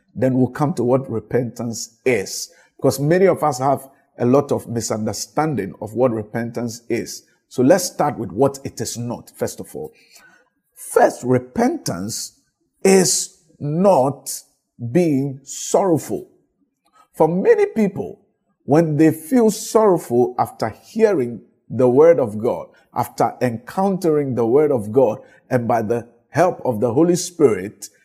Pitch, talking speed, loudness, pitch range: 140 Hz, 135 wpm, -19 LUFS, 120-185 Hz